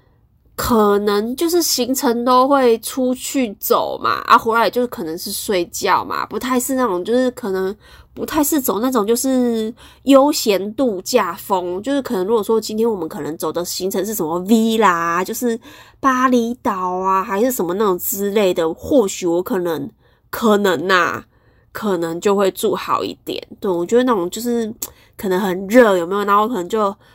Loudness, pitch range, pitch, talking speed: -17 LUFS, 190-250 Hz, 220 Hz, 265 characters per minute